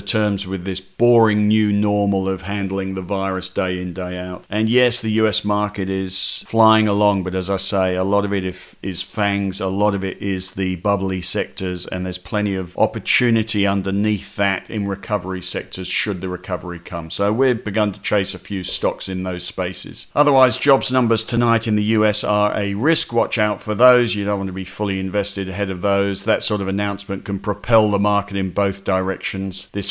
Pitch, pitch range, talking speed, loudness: 100 Hz, 95-105 Hz, 205 wpm, -19 LUFS